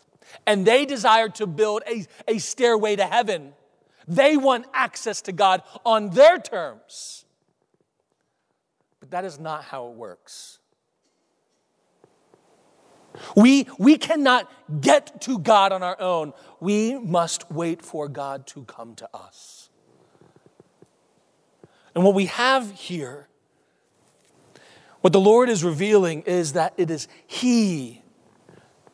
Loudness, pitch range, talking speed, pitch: -21 LUFS, 170-235 Hz, 120 wpm, 200 Hz